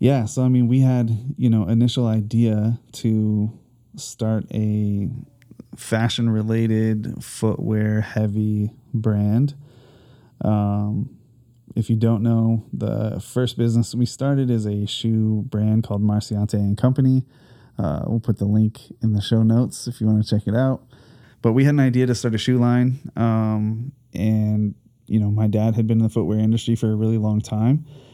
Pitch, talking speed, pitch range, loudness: 115 Hz, 170 wpm, 110-125 Hz, -21 LUFS